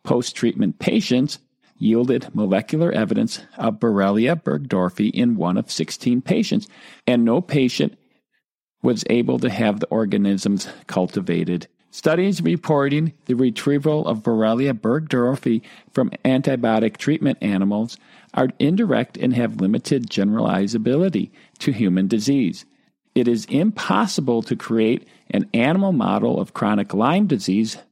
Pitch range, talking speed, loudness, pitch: 110-160 Hz, 120 wpm, -20 LUFS, 130 Hz